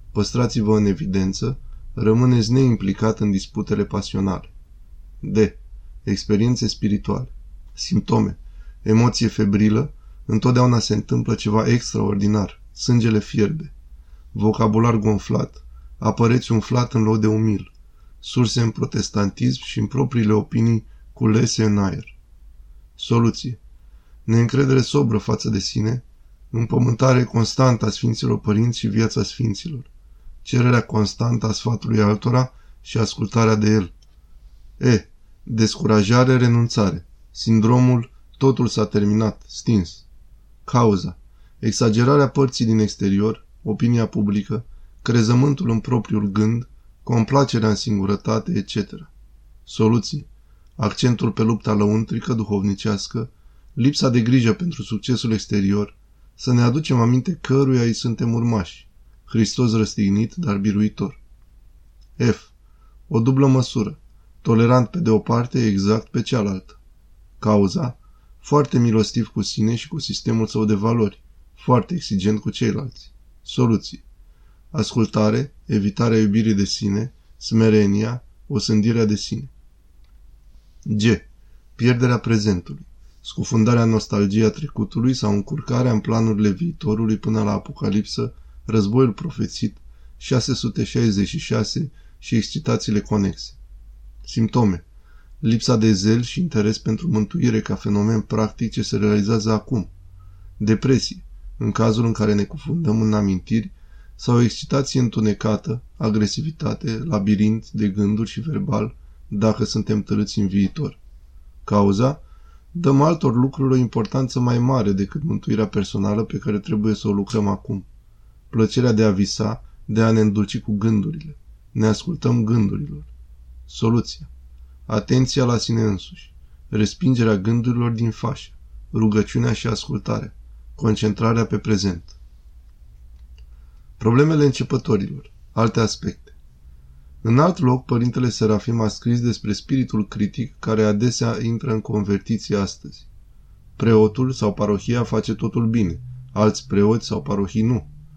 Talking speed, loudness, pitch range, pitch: 115 wpm, -20 LUFS, 100-120 Hz, 110 Hz